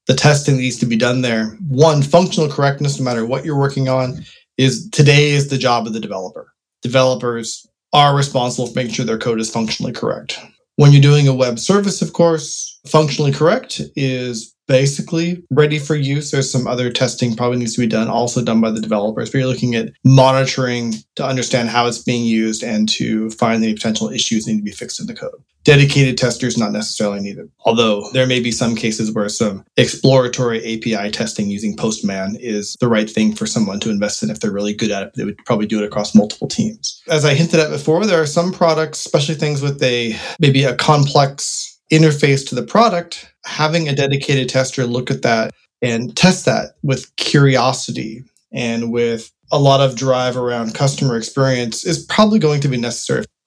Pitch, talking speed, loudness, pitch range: 130 Hz, 200 wpm, -16 LUFS, 115-150 Hz